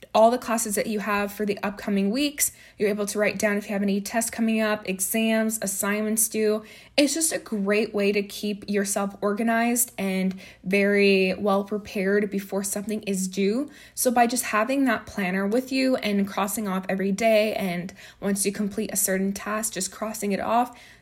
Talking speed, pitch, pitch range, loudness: 190 wpm, 205 Hz, 200-220 Hz, -24 LUFS